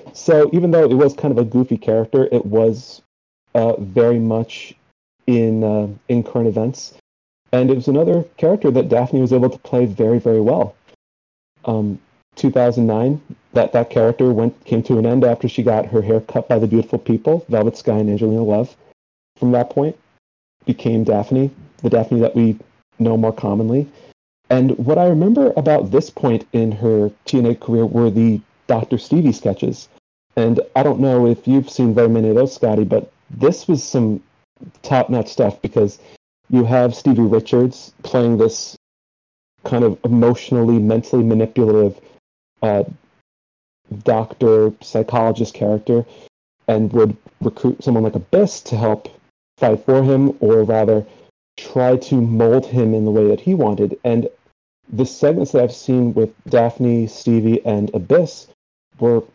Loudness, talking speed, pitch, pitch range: -16 LUFS, 160 wpm, 115 Hz, 110-125 Hz